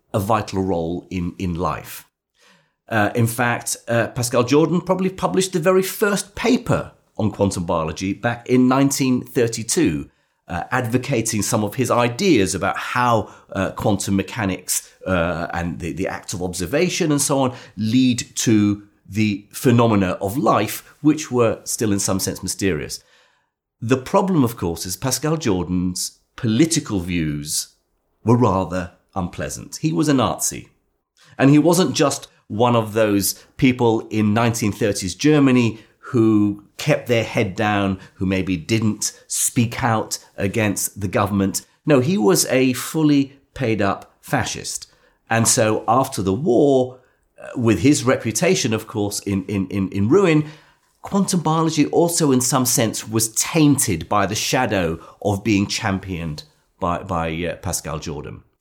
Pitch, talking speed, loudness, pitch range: 110 Hz, 145 wpm, -20 LUFS, 95-130 Hz